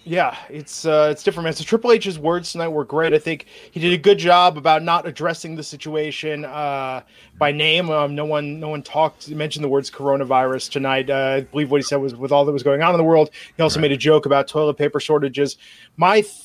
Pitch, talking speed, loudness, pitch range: 150 Hz, 240 wpm, -19 LUFS, 145-165 Hz